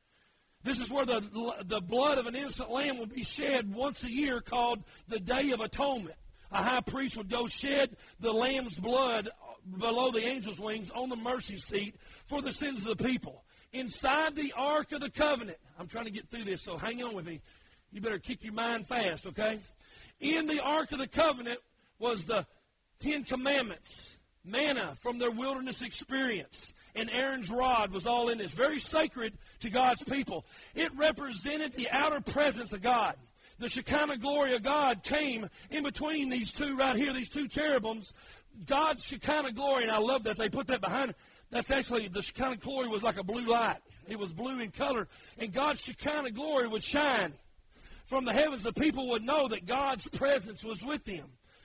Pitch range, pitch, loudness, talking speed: 225-275 Hz, 250 Hz, -32 LUFS, 190 wpm